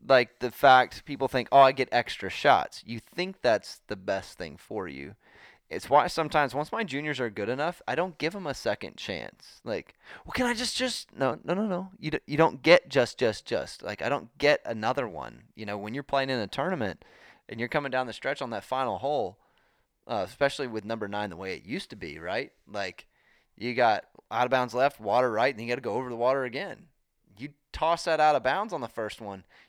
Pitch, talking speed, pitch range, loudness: 135 Hz, 235 wpm, 115-160 Hz, -28 LUFS